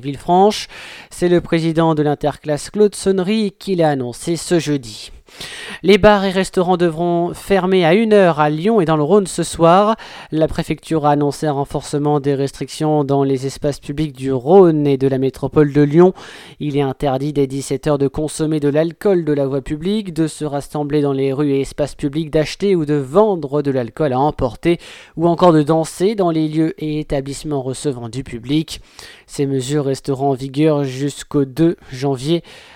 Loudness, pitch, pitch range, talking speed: -17 LUFS, 150 Hz, 140-175 Hz, 180 wpm